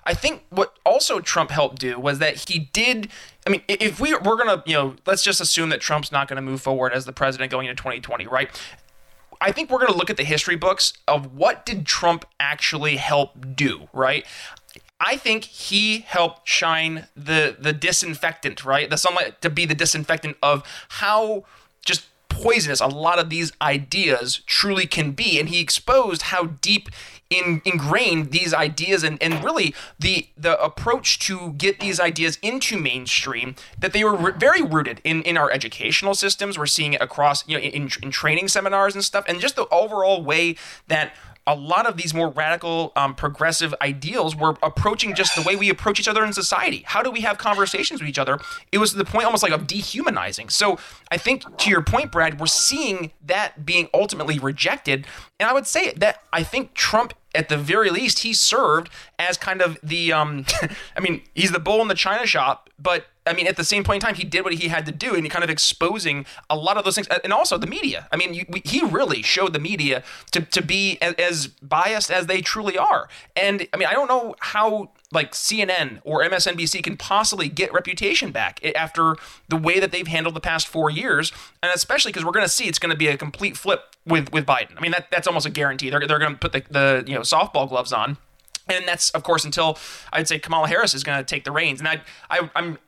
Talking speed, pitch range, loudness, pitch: 220 wpm, 150-195 Hz, -20 LUFS, 165 Hz